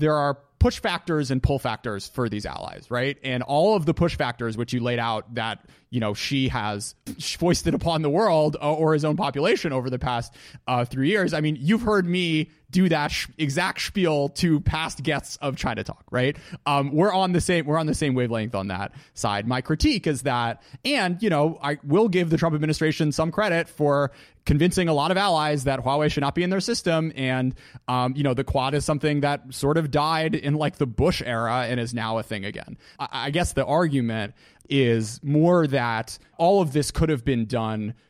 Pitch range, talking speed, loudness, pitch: 125-165 Hz, 215 wpm, -24 LUFS, 145 Hz